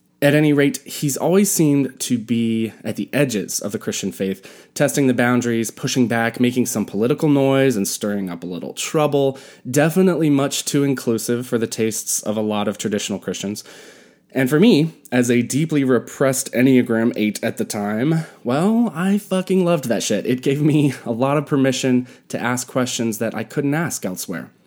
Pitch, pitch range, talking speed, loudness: 130 Hz, 115-145 Hz, 185 wpm, -19 LUFS